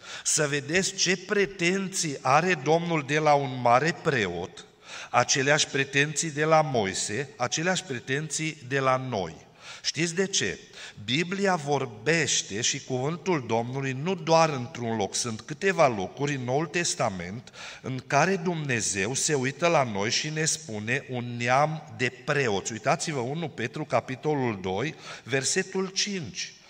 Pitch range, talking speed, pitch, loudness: 130-170 Hz, 135 wpm, 150 Hz, -26 LUFS